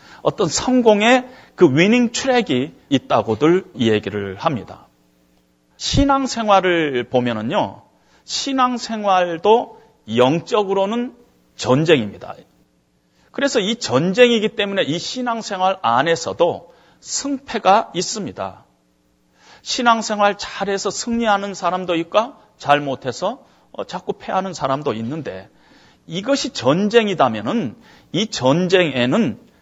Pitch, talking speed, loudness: 190 Hz, 235 characters per minute, -18 LUFS